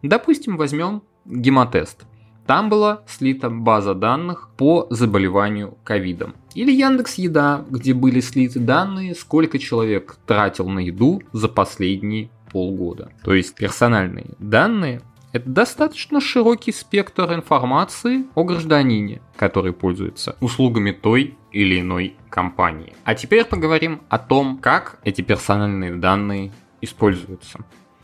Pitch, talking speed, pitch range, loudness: 125 Hz, 115 wpm, 100-165 Hz, -19 LUFS